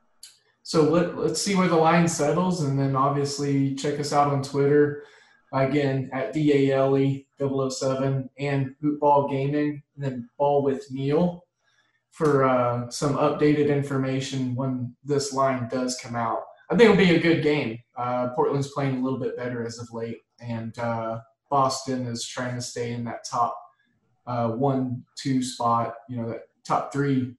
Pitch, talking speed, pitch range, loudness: 135 Hz, 160 wpm, 125-145 Hz, -24 LUFS